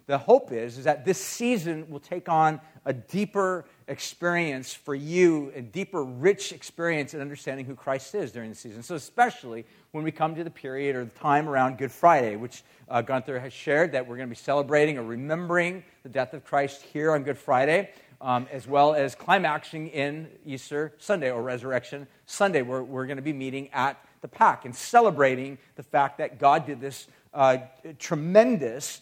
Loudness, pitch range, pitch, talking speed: -26 LUFS, 130-160 Hz, 140 Hz, 190 wpm